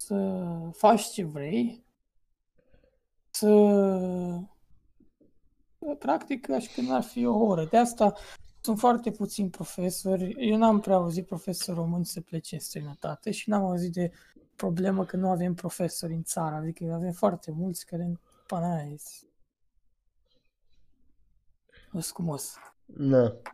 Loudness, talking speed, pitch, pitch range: -28 LUFS, 120 wpm, 185 Hz, 170-210 Hz